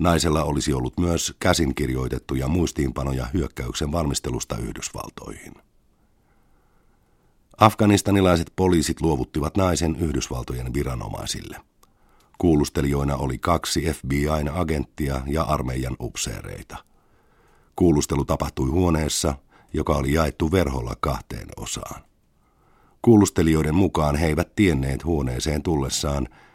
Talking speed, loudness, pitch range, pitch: 85 wpm, -23 LUFS, 70-85 Hz, 75 Hz